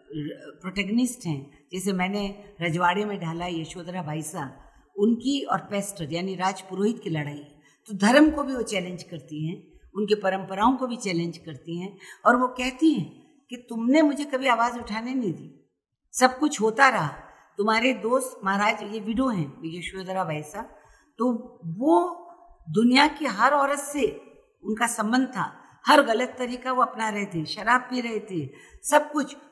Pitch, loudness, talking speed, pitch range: 215 Hz, -25 LUFS, 160 wpm, 180-255 Hz